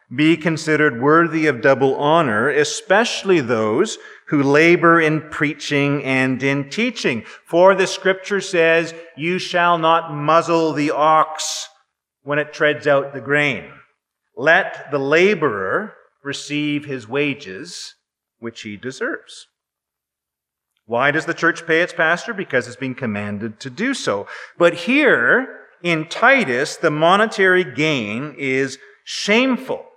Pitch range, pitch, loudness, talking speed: 140-175 Hz, 155 Hz, -17 LUFS, 125 wpm